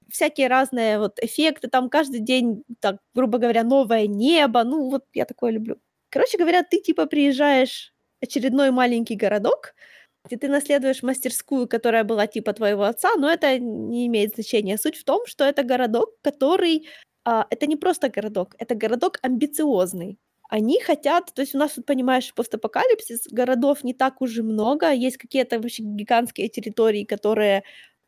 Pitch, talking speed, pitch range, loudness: 255 Hz, 160 wpm, 225-285 Hz, -22 LUFS